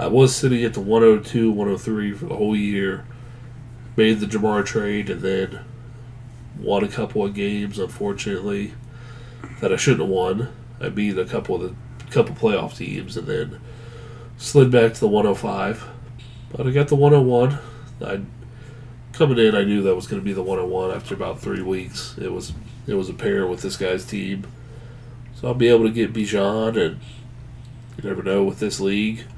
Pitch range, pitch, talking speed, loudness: 105-125 Hz, 115 Hz, 185 wpm, -21 LUFS